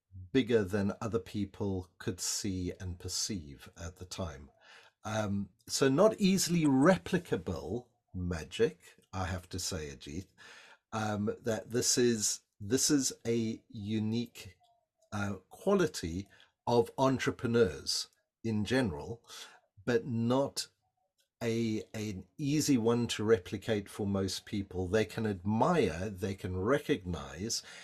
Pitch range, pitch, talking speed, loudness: 95-120 Hz, 110 Hz, 115 wpm, -33 LUFS